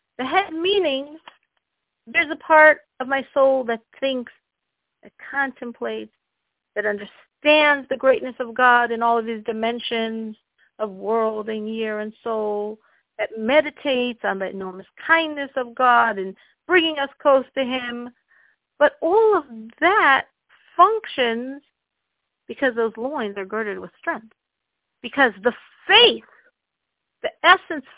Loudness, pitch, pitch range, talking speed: -20 LUFS, 255 Hz, 225-295 Hz, 130 wpm